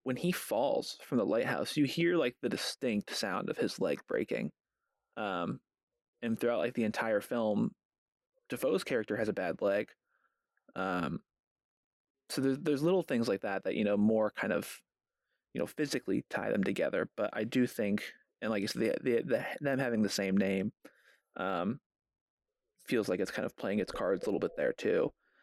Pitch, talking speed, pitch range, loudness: 130 Hz, 185 wpm, 110-180 Hz, -34 LUFS